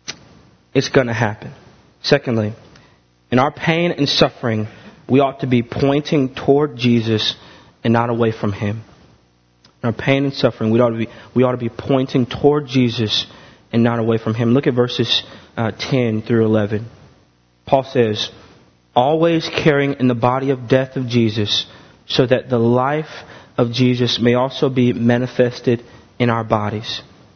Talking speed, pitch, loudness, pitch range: 160 wpm, 120 Hz, -17 LUFS, 110-135 Hz